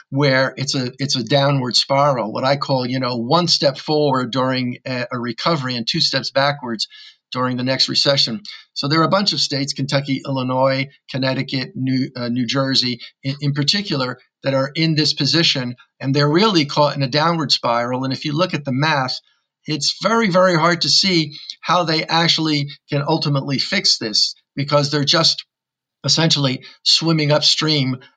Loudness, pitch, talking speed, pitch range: -17 LUFS, 140 Hz, 175 wpm, 130-155 Hz